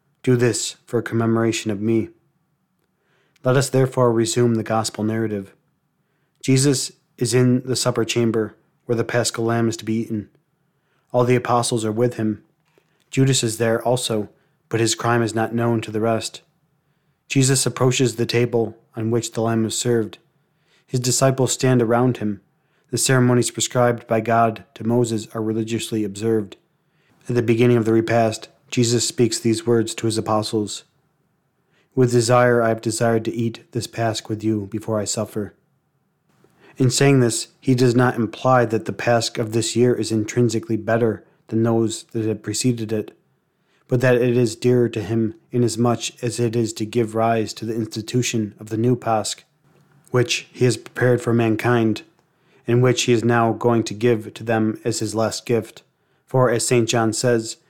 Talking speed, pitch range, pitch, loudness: 175 wpm, 110-125 Hz, 120 Hz, -20 LUFS